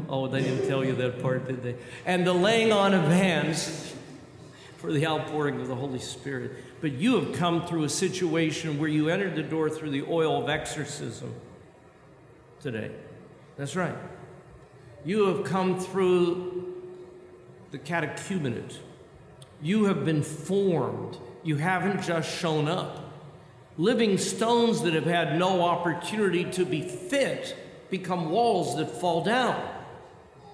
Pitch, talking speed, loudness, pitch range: 165 Hz, 140 wpm, -27 LUFS, 145-185 Hz